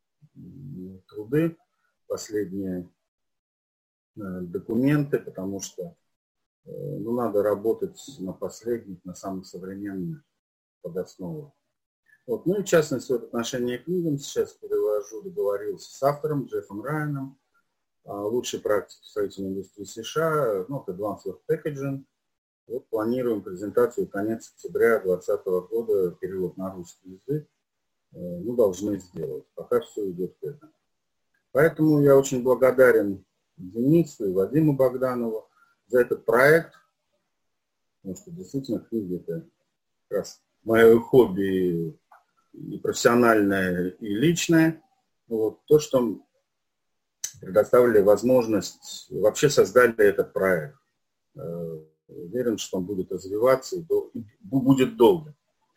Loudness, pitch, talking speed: -24 LUFS, 140 Hz, 110 wpm